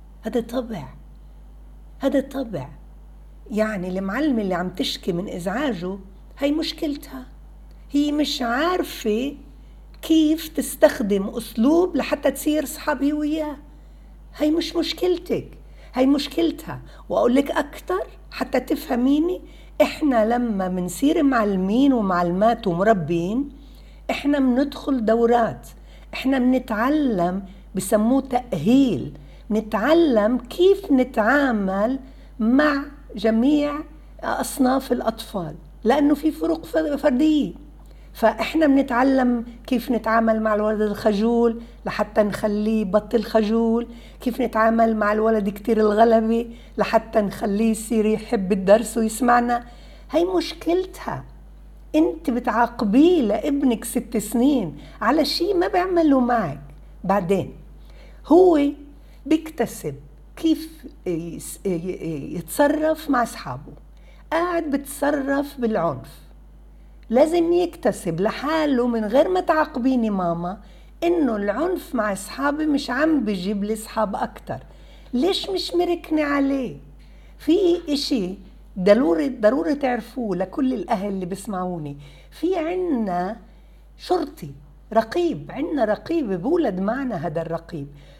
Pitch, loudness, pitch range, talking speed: 240 Hz, -21 LUFS, 210-295 Hz, 95 wpm